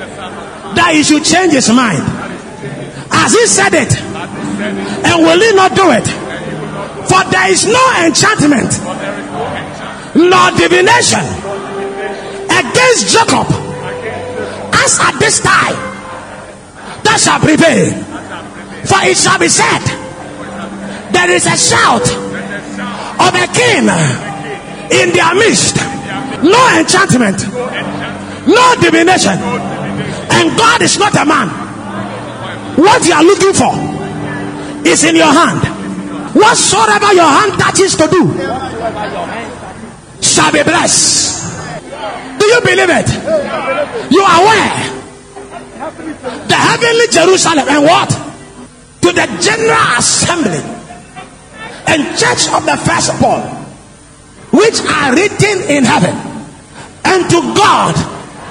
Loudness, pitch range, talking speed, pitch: -9 LUFS, 310-415 Hz, 105 wpm, 360 Hz